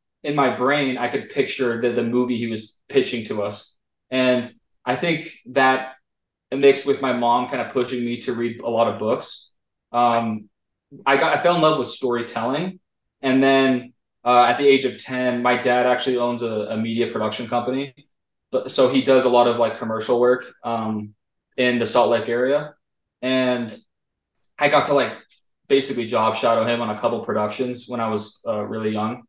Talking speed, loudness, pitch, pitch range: 190 wpm, -21 LUFS, 125 Hz, 115-130 Hz